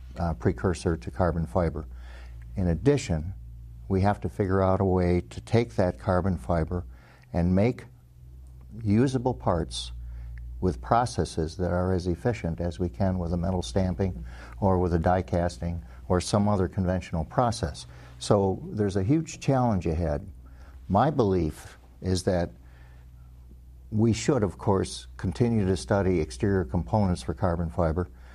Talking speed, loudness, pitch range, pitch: 145 wpm, -27 LUFS, 70-100 Hz, 90 Hz